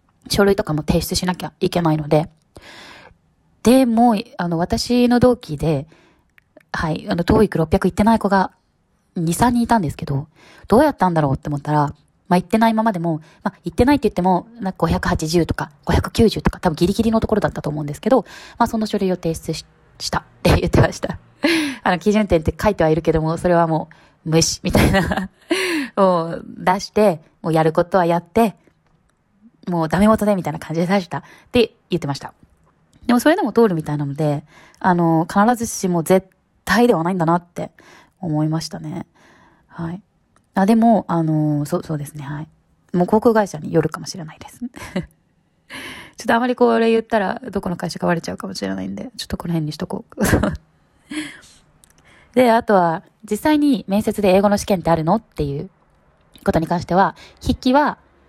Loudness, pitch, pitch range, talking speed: -19 LUFS, 185 Hz, 160-220 Hz, 360 characters per minute